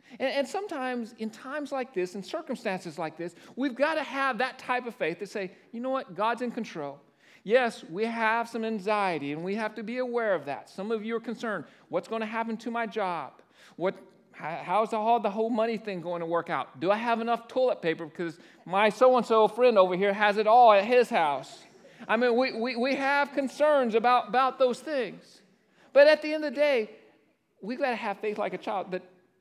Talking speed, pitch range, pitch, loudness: 220 wpm, 200-255 Hz, 225 Hz, -27 LUFS